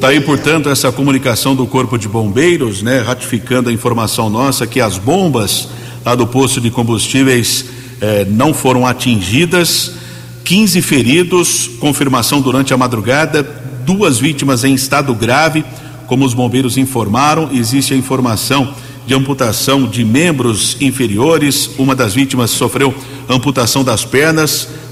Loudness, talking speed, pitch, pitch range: -12 LUFS, 135 wpm, 130 Hz, 120-140 Hz